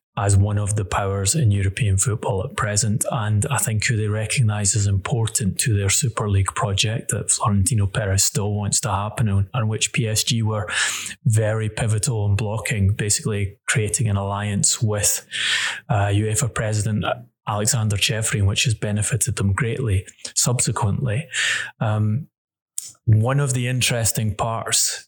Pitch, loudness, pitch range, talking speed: 110 Hz, -21 LUFS, 105-120 Hz, 145 wpm